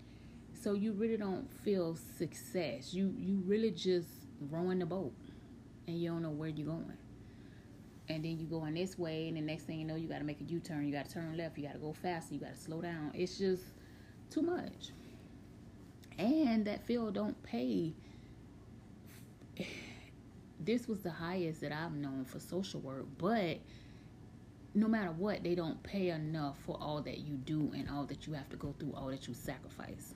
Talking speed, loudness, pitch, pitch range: 195 wpm, -39 LUFS, 160 Hz, 145-185 Hz